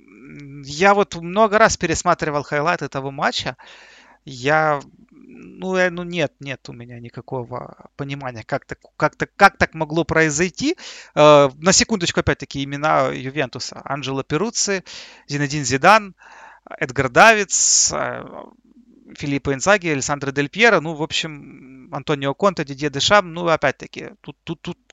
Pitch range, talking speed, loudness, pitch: 140-190 Hz, 130 wpm, -18 LUFS, 155 Hz